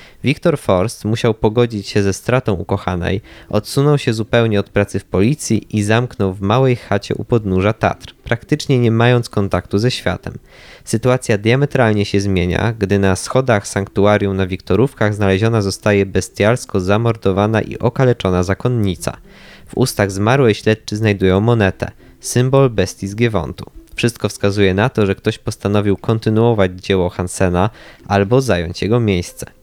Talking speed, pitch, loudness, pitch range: 140 wpm, 105 Hz, -16 LUFS, 95-120 Hz